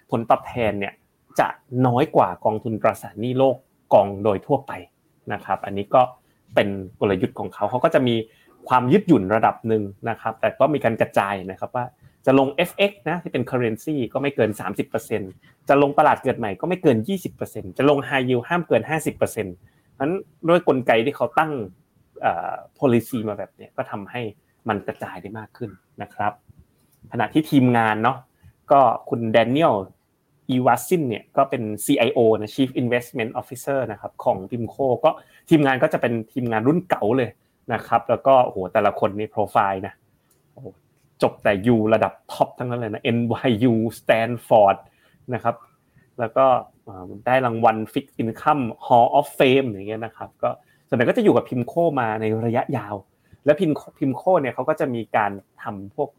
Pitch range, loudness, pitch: 110-140 Hz, -21 LUFS, 125 Hz